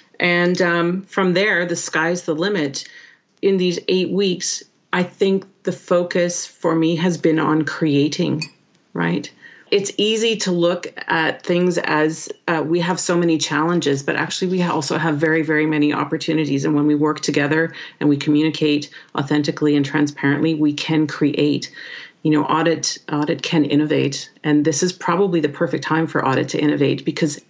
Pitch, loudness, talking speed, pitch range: 160 Hz, -19 LUFS, 170 wpm, 150-175 Hz